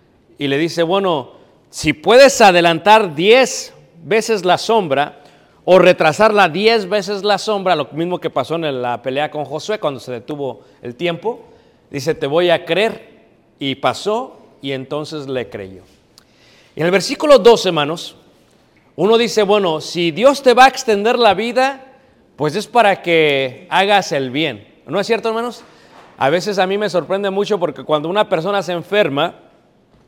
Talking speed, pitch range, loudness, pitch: 165 wpm, 150-220 Hz, -15 LUFS, 180 Hz